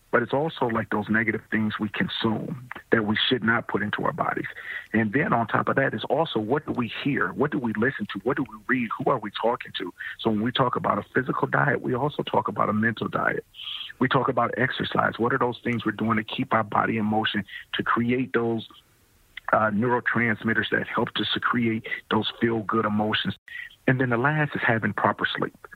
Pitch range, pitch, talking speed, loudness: 110-120 Hz, 115 Hz, 225 wpm, -25 LUFS